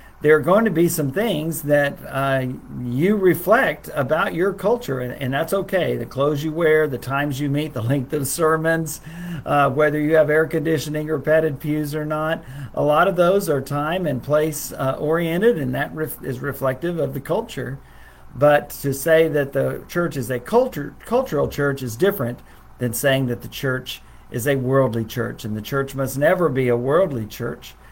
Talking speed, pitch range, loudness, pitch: 195 wpm, 135-160 Hz, -21 LUFS, 145 Hz